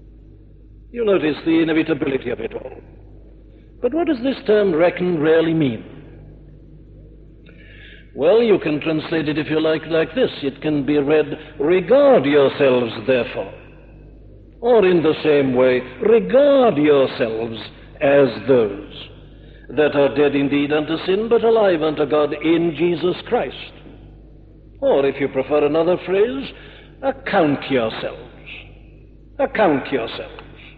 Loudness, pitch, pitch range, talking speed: -18 LUFS, 155 Hz, 140-185 Hz, 125 wpm